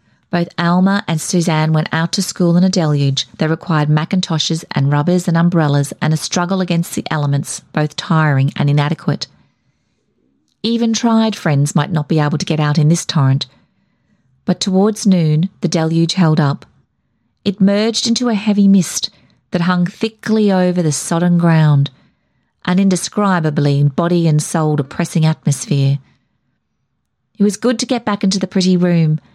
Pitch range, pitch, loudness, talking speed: 155-190 Hz, 170 Hz, -15 LUFS, 160 wpm